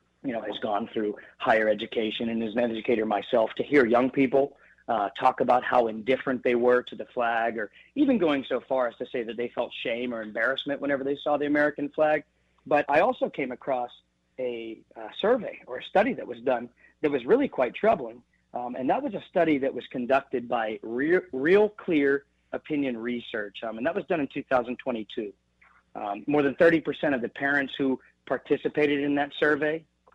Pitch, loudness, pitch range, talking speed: 135 Hz, -27 LUFS, 115-145 Hz, 195 wpm